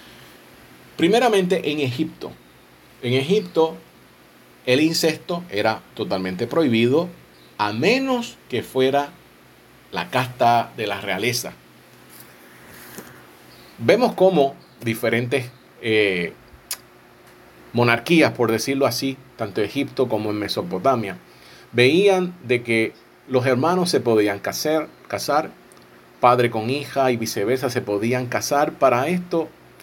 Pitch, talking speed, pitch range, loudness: 125 Hz, 105 wpm, 110-150 Hz, -21 LUFS